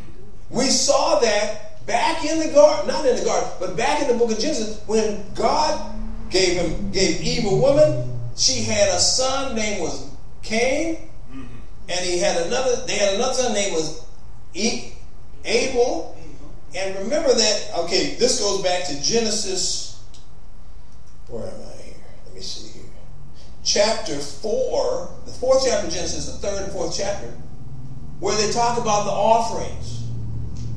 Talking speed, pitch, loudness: 155 wpm, 200 Hz, -21 LUFS